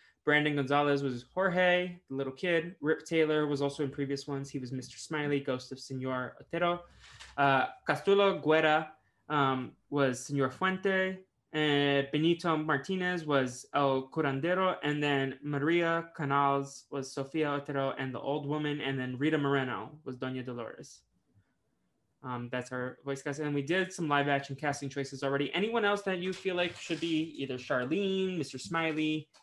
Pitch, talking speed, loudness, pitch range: 145 Hz, 160 wpm, -31 LUFS, 135-165 Hz